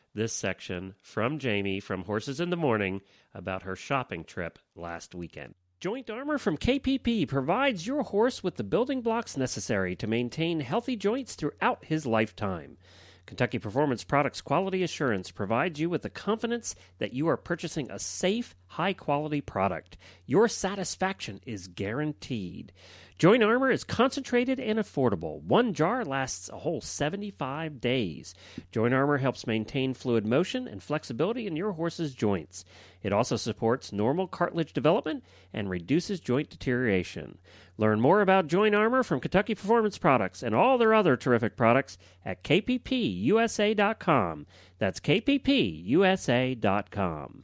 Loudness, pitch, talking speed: -28 LUFS, 135 Hz, 140 wpm